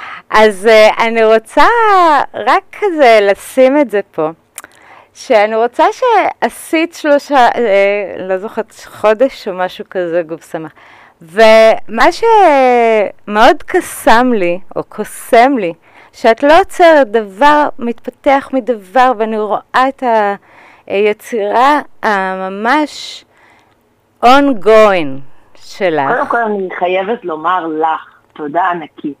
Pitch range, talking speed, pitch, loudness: 200-280 Hz, 100 wpm, 230 Hz, -11 LUFS